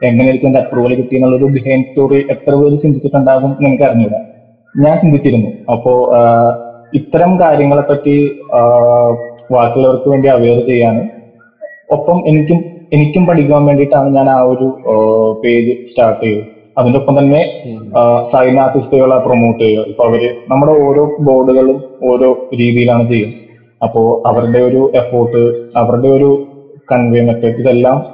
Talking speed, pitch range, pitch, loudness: 120 wpm, 120-140 Hz, 130 Hz, -10 LUFS